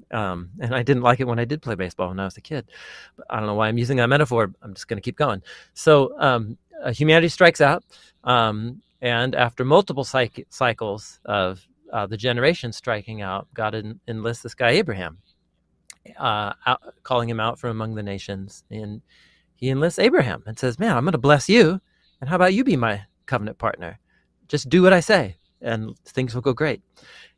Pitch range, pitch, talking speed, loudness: 110-140 Hz, 120 Hz, 205 wpm, -21 LUFS